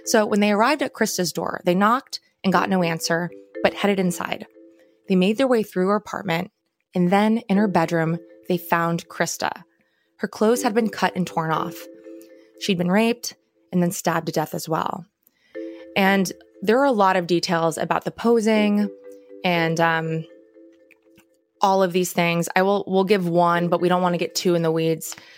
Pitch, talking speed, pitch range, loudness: 175 Hz, 190 wpm, 165-200 Hz, -21 LUFS